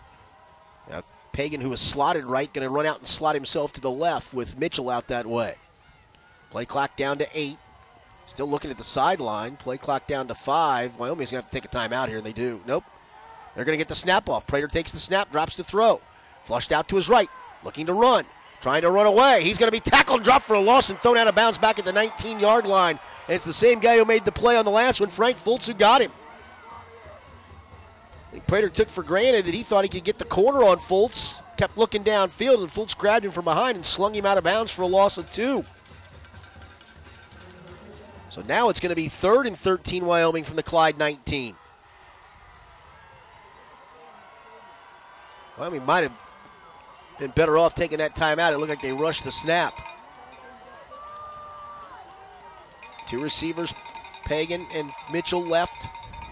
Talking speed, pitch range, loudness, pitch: 195 wpm, 145-220 Hz, -22 LUFS, 175 Hz